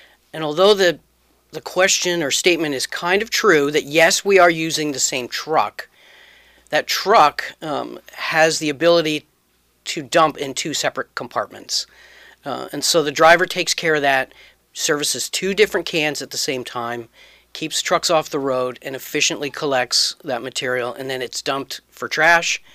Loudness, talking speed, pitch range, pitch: -18 LUFS, 170 wpm, 130-170 Hz, 155 Hz